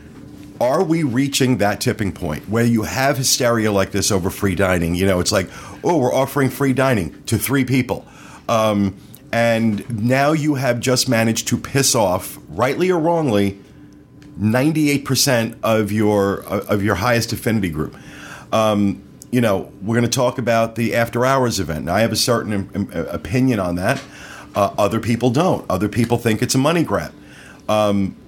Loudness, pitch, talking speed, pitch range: -18 LUFS, 115 Hz, 170 wpm, 100-130 Hz